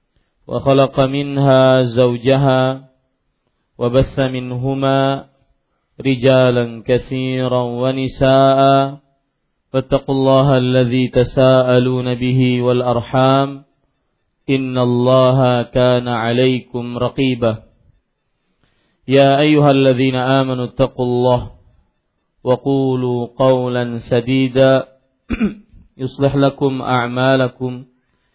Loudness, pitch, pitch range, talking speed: -15 LUFS, 130 Hz, 125-135 Hz, 65 wpm